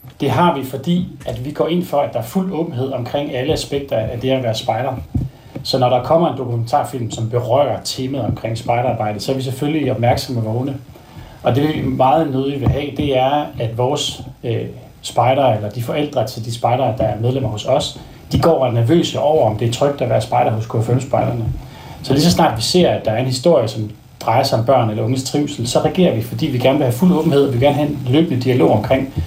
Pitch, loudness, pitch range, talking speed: 130 Hz, -17 LUFS, 120-145 Hz, 240 wpm